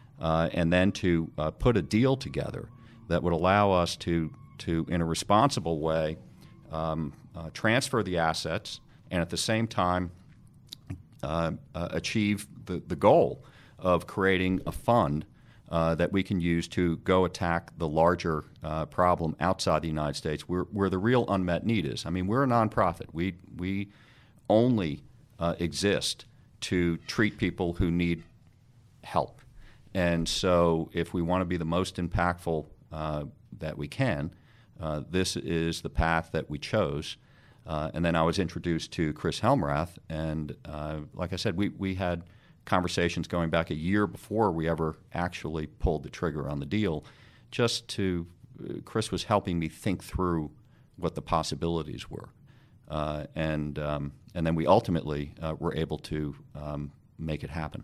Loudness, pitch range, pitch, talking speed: -29 LUFS, 80-100 Hz, 85 Hz, 165 wpm